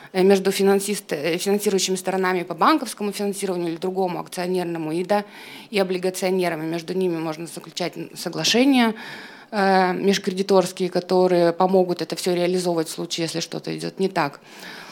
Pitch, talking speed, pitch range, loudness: 185 Hz, 125 wpm, 170-195 Hz, -22 LUFS